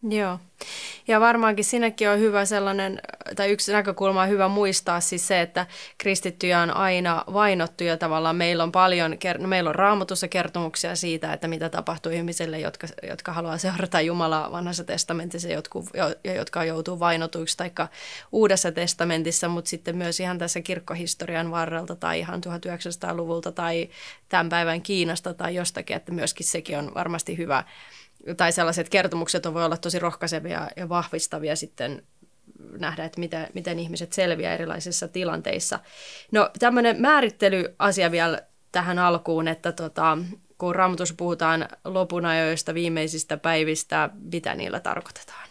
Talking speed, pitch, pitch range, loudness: 140 wpm, 175 Hz, 165-185 Hz, -24 LUFS